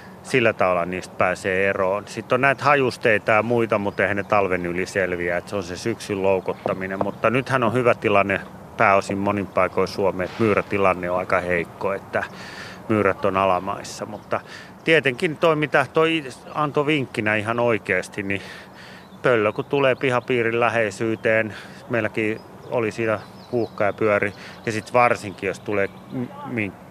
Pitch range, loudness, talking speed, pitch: 100-125 Hz, -22 LUFS, 150 wpm, 110 Hz